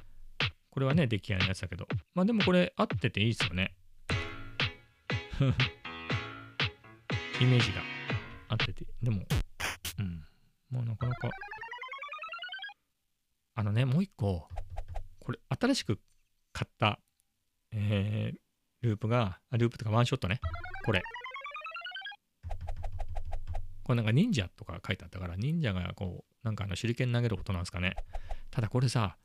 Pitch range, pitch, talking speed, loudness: 95-125 Hz, 110 Hz, 265 characters per minute, -33 LUFS